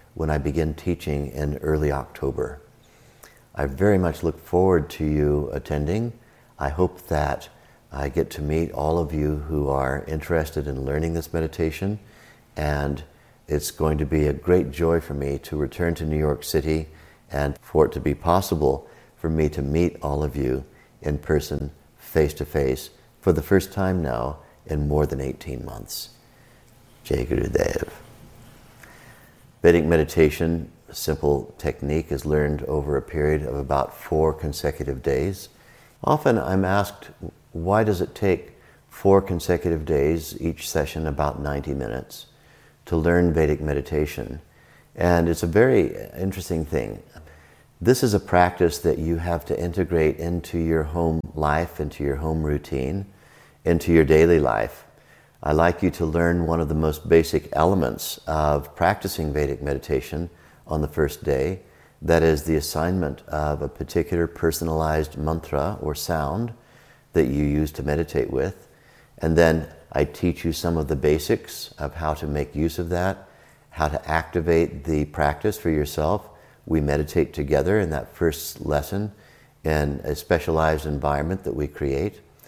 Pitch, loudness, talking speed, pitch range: 80 Hz, -24 LUFS, 155 wpm, 75-85 Hz